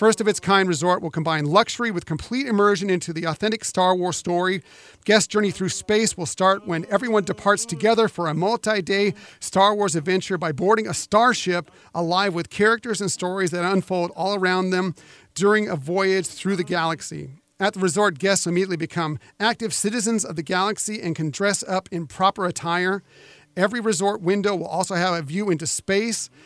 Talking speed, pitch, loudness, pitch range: 185 wpm, 185 Hz, -22 LUFS, 175-205 Hz